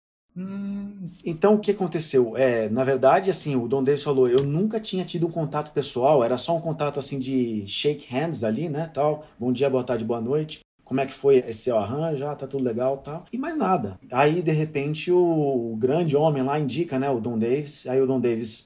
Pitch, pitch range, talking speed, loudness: 145 Hz, 130-165 Hz, 220 wpm, -24 LUFS